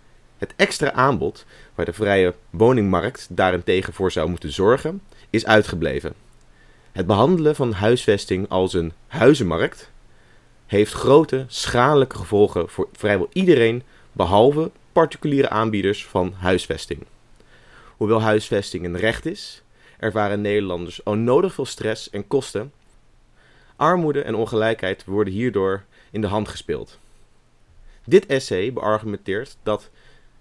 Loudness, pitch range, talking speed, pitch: -20 LUFS, 95-125 Hz, 115 wpm, 105 Hz